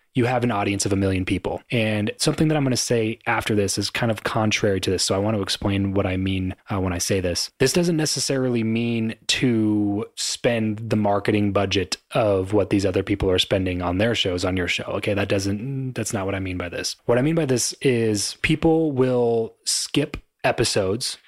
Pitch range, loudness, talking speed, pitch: 100-120 Hz, -22 LUFS, 220 wpm, 105 Hz